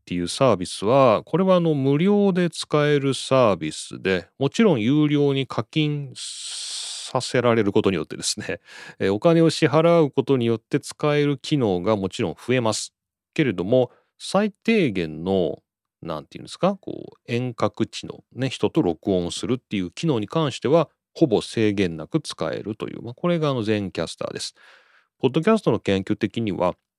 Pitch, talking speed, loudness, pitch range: 130 Hz, 345 characters per minute, -22 LUFS, 105-155 Hz